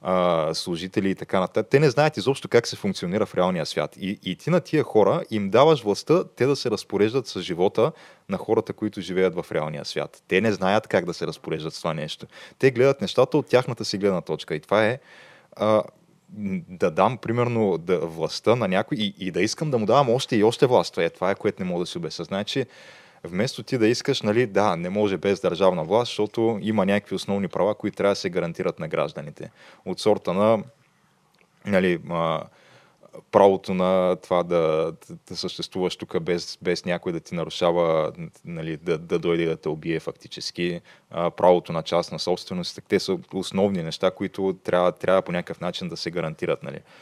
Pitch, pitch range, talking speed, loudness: 100 Hz, 90-125 Hz, 195 wpm, -24 LUFS